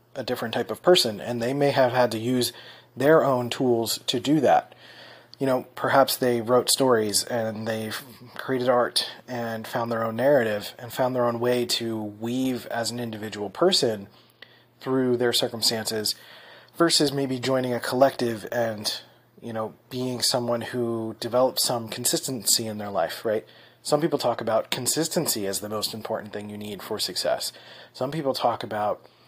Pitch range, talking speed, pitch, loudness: 110-130 Hz, 170 wpm, 120 Hz, -24 LUFS